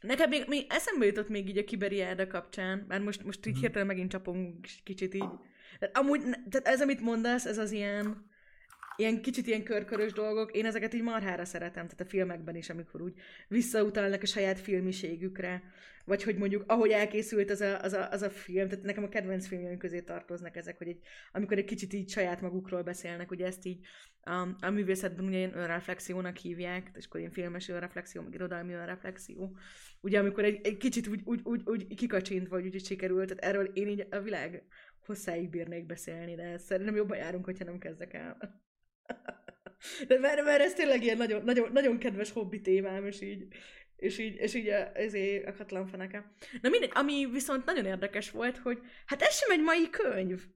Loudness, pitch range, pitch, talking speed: -33 LUFS, 185-220 Hz, 200 Hz, 190 wpm